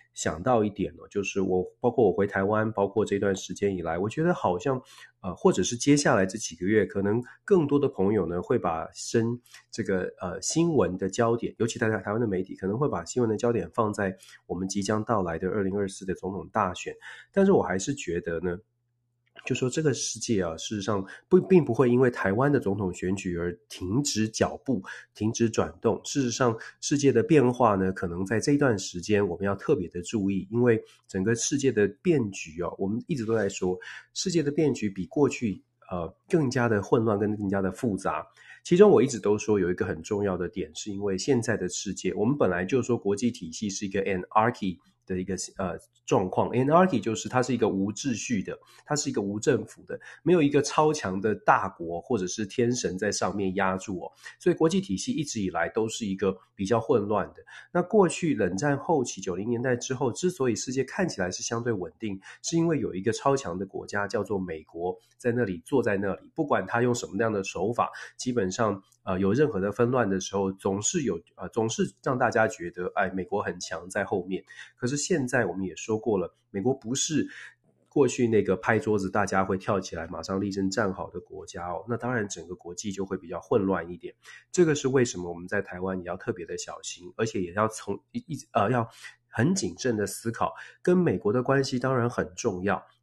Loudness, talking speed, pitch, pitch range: -27 LUFS, 320 characters per minute, 110 Hz, 95-125 Hz